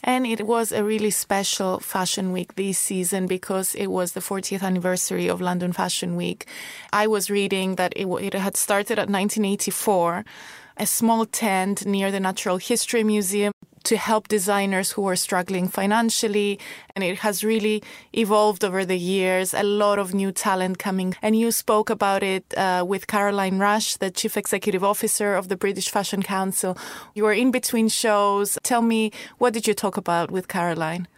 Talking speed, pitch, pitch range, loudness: 175 wpm, 200 Hz, 185-215 Hz, -22 LUFS